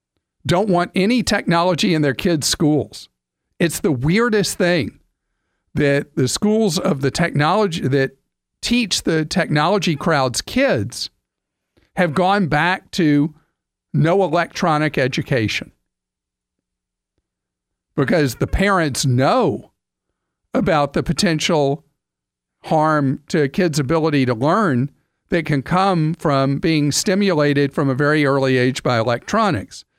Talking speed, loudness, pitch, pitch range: 115 wpm, -18 LUFS, 155 Hz, 135-180 Hz